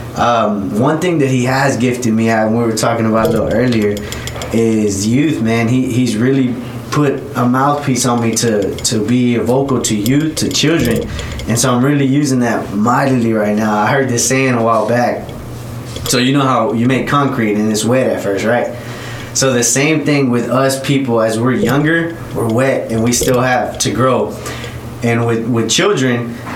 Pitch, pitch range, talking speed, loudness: 120 Hz, 115-130 Hz, 195 wpm, -14 LUFS